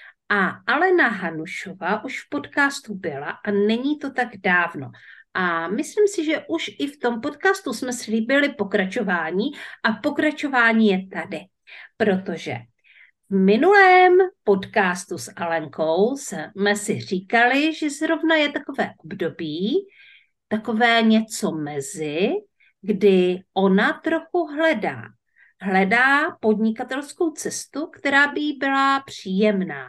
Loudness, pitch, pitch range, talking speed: -21 LUFS, 225 Hz, 190-295 Hz, 115 wpm